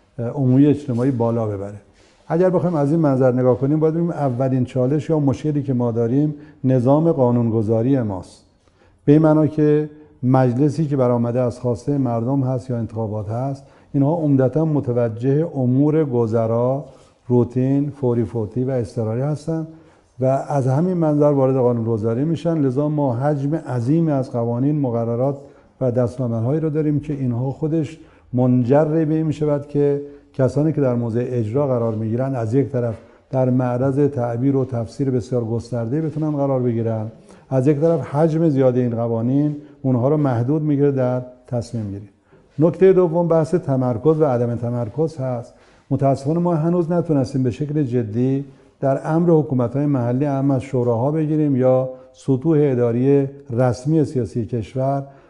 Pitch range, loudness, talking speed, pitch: 120-150 Hz, -19 LUFS, 150 wpm, 135 Hz